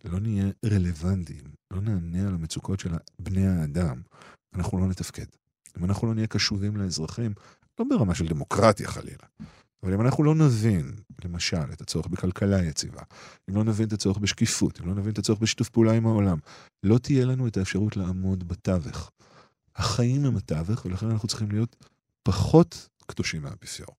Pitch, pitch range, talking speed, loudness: 100 Hz, 90-115 Hz, 165 wpm, -26 LUFS